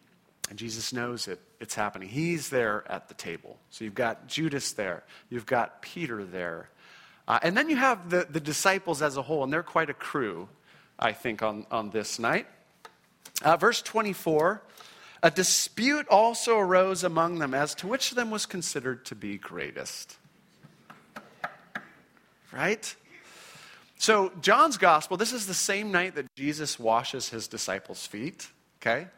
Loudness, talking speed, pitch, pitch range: -27 LUFS, 160 wpm, 155 Hz, 115-190 Hz